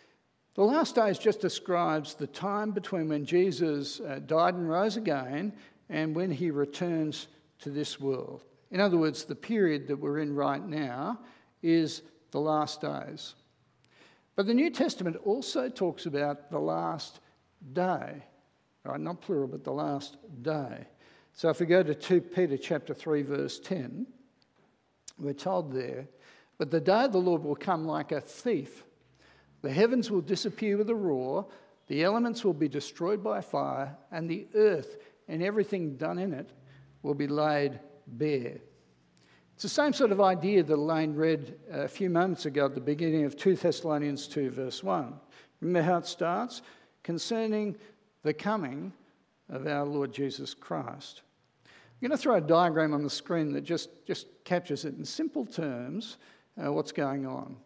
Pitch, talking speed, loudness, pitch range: 165 Hz, 165 wpm, -30 LUFS, 145-195 Hz